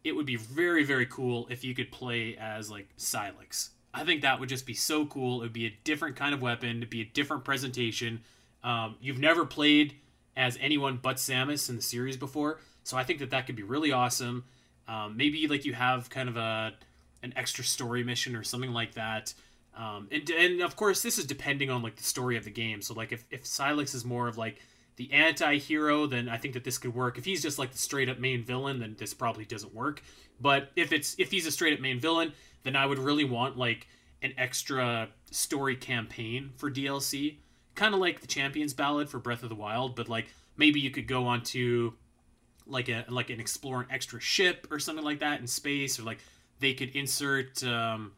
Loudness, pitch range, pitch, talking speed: -30 LUFS, 120-140 Hz, 130 Hz, 225 wpm